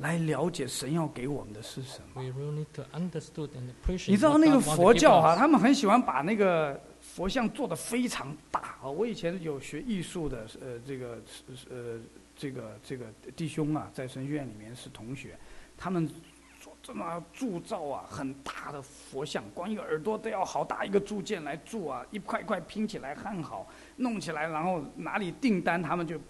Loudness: -30 LUFS